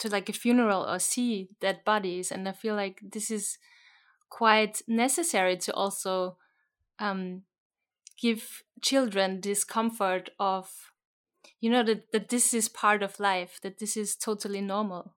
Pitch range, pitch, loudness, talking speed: 195-225 Hz, 210 Hz, -28 LUFS, 150 wpm